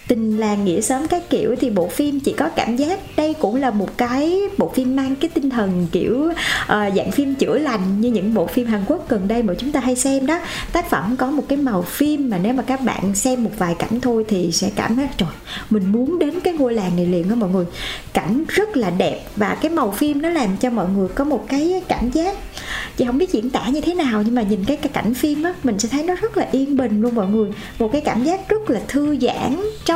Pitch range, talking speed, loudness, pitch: 220-300 Hz, 260 wpm, -19 LUFS, 255 Hz